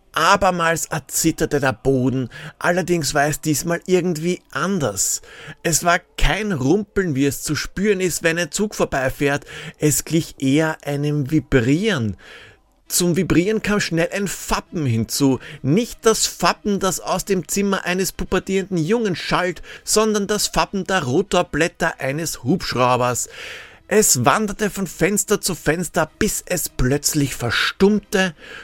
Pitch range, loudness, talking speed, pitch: 145-190 Hz, -19 LUFS, 130 wpm, 165 Hz